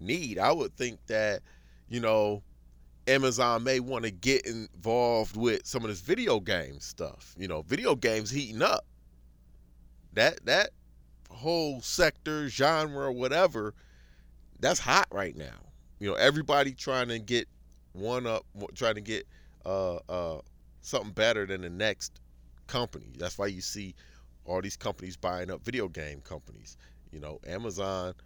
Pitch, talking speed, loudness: 95 Hz, 150 wpm, -30 LUFS